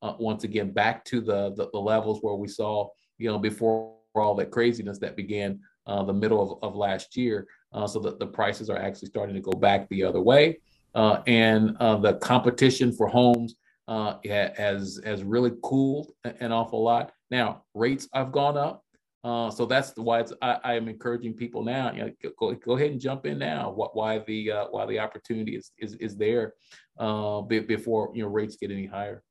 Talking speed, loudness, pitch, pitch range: 205 wpm, -27 LUFS, 110 Hz, 105-120 Hz